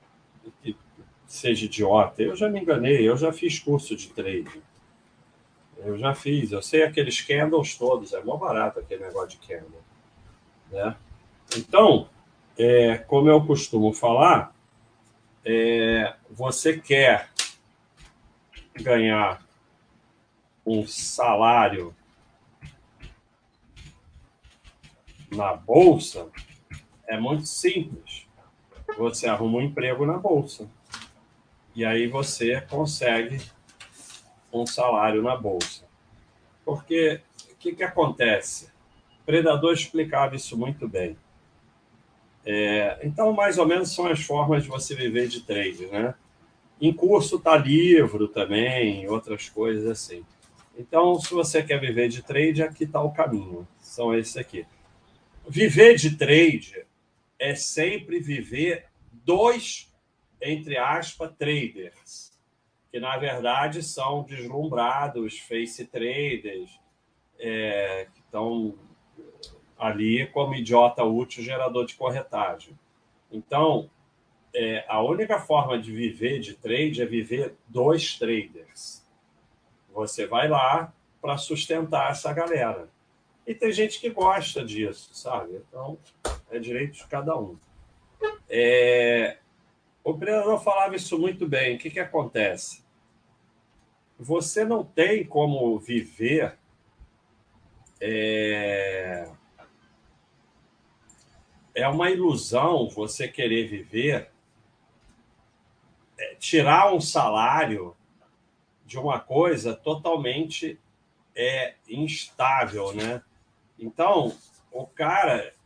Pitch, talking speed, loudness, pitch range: 130 Hz, 105 wpm, -24 LUFS, 115-160 Hz